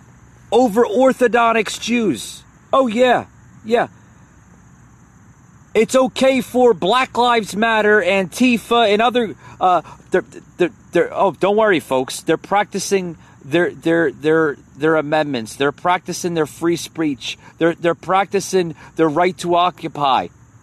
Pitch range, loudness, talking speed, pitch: 160-230 Hz, -17 LUFS, 125 wpm, 180 Hz